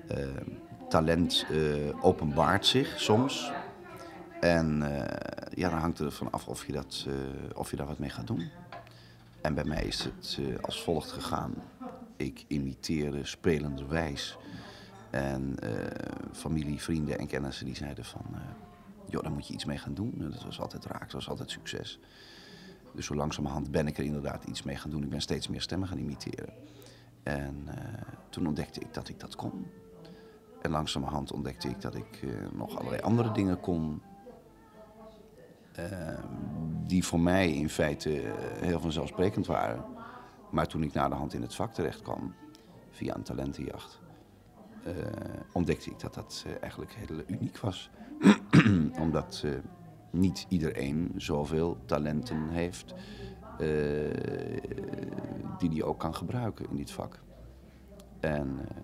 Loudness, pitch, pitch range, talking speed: -33 LUFS, 75 Hz, 70-85 Hz, 155 wpm